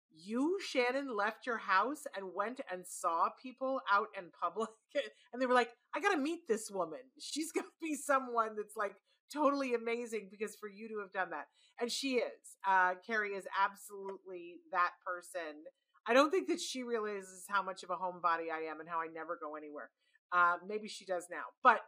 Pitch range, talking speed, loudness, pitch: 185-260 Hz, 200 wpm, -36 LUFS, 210 Hz